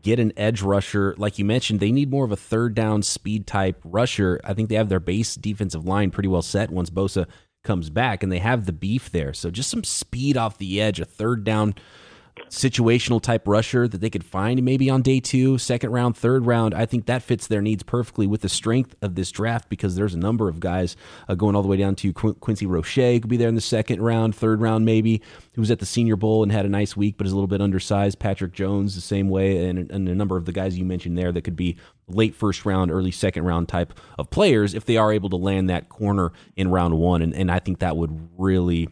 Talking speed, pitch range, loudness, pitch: 250 wpm, 95-115 Hz, -22 LUFS, 100 Hz